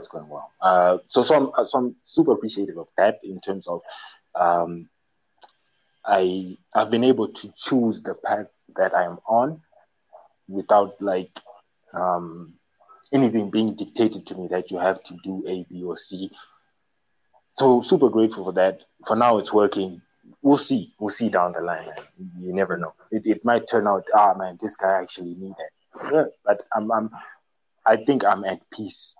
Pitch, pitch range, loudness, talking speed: 95 Hz, 90-110 Hz, -22 LUFS, 175 wpm